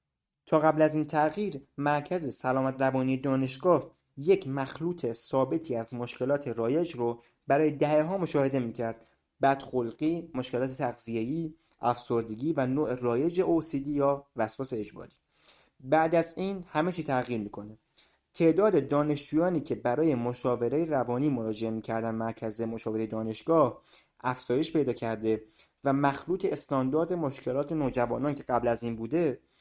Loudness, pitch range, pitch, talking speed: -29 LUFS, 120-155 Hz, 135 Hz, 130 wpm